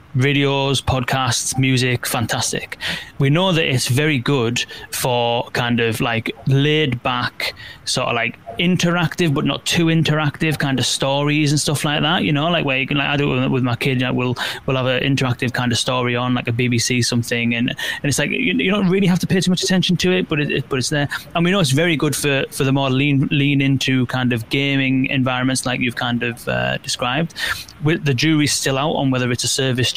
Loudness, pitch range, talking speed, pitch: -18 LUFS, 125-150 Hz, 225 wpm, 135 Hz